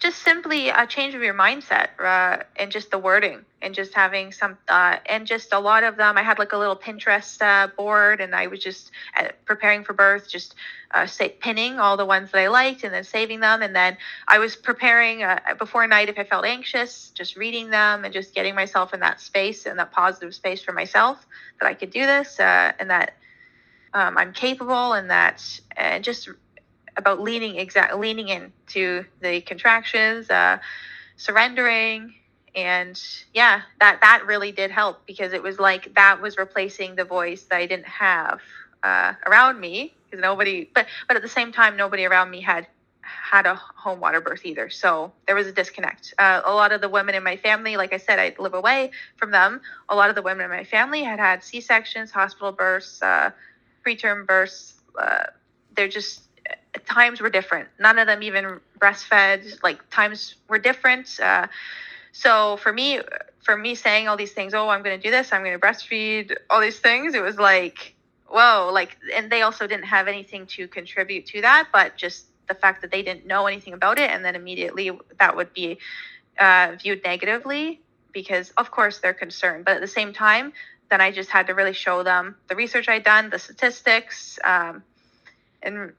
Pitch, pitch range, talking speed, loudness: 205 Hz, 190-225 Hz, 200 wpm, -19 LUFS